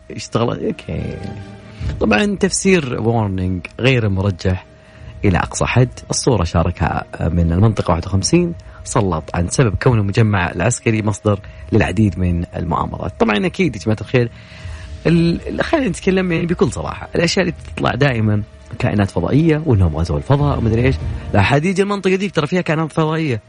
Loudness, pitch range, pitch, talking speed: -17 LUFS, 90-145 Hz, 110 Hz, 135 wpm